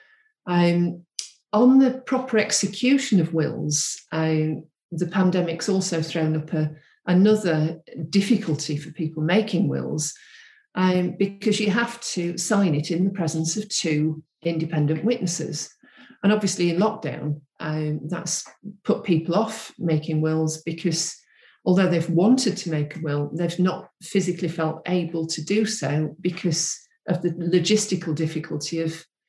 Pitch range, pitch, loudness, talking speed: 160-205 Hz, 175 Hz, -23 LUFS, 135 wpm